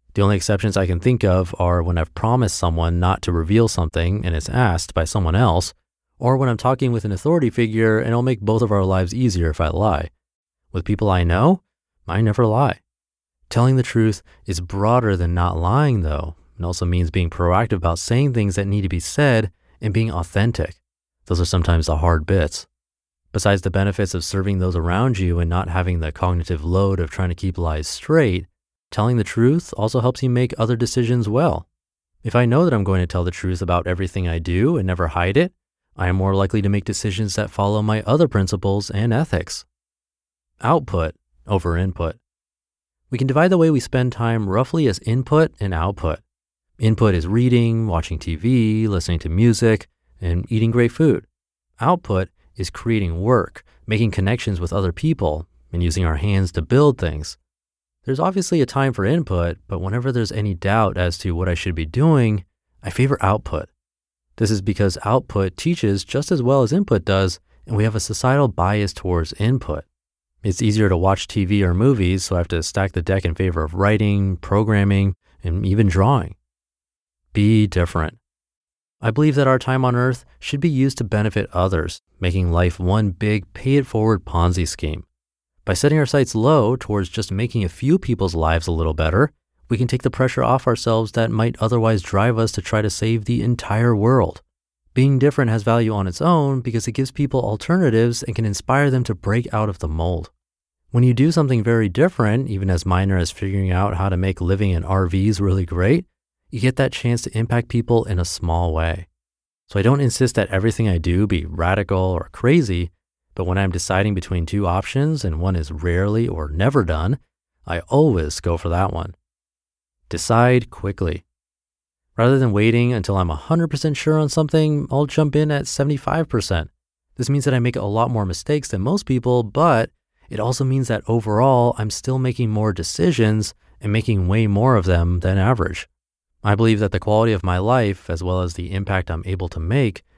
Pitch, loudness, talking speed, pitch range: 100 Hz, -19 LUFS, 195 wpm, 85-120 Hz